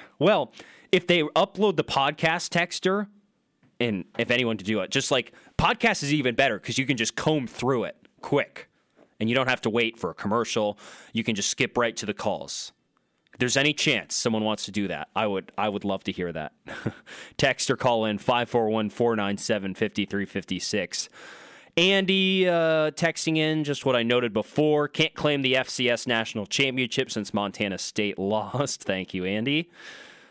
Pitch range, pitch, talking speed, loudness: 110-155 Hz, 125 Hz, 175 wpm, -25 LUFS